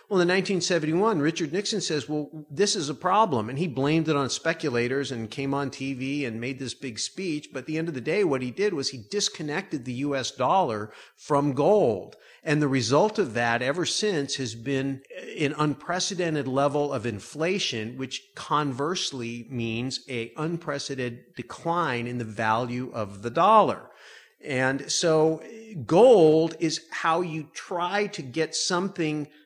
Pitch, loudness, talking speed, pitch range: 145 Hz, -26 LUFS, 165 wpm, 130-165 Hz